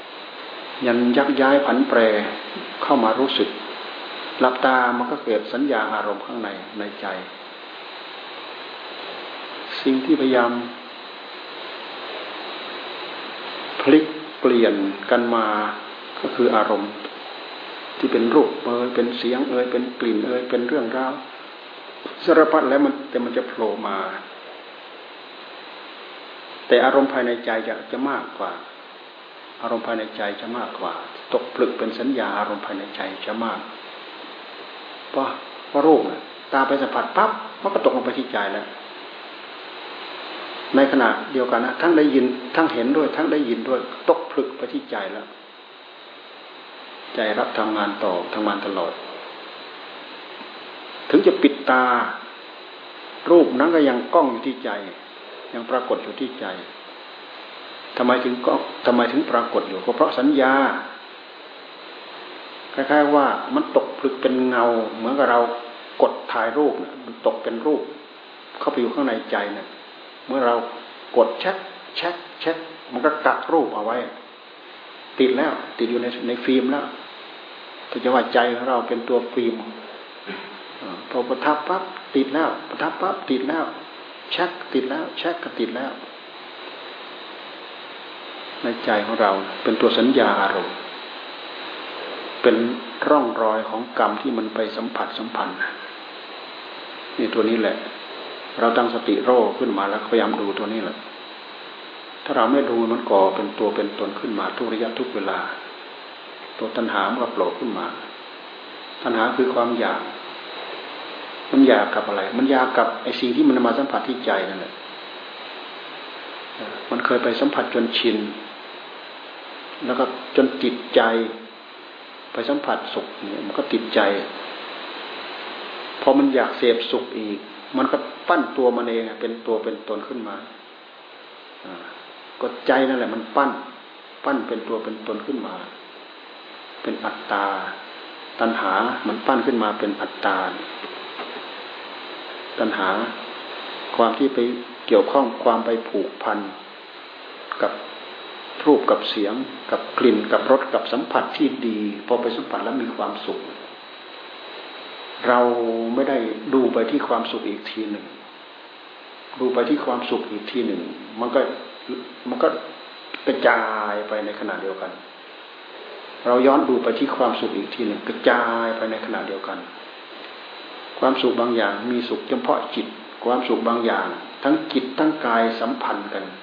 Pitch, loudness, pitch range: 120 Hz, -22 LUFS, 115-130 Hz